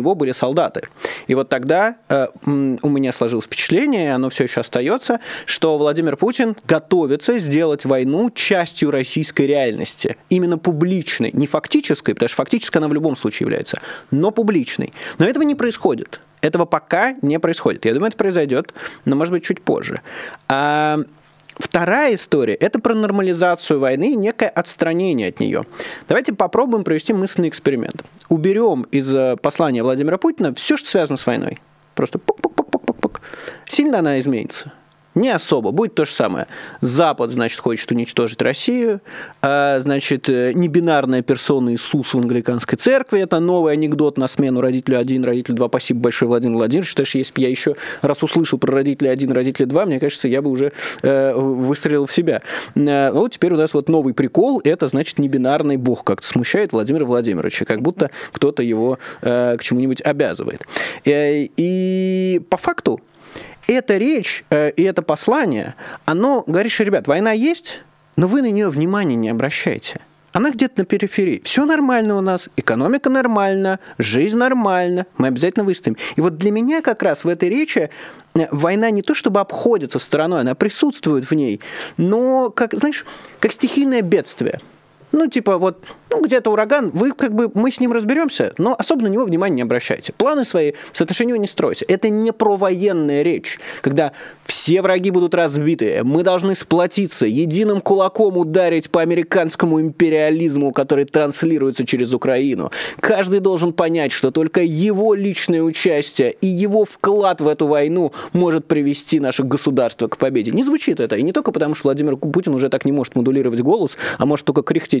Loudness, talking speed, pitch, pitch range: -17 LUFS, 165 wpm, 165 Hz, 140-205 Hz